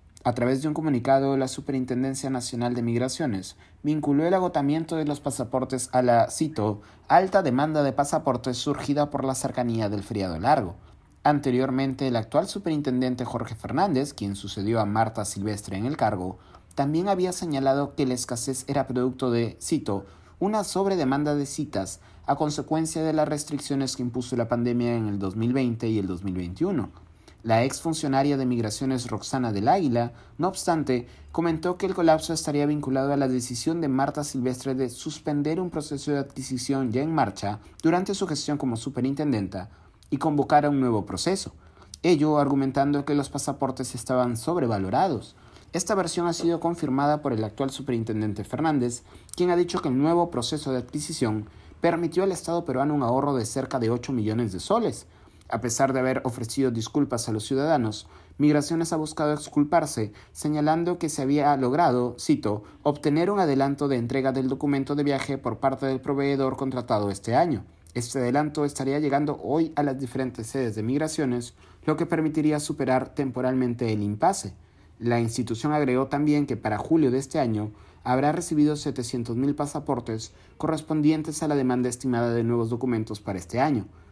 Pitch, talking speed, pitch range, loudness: 135 Hz, 165 wpm, 115-150 Hz, -26 LUFS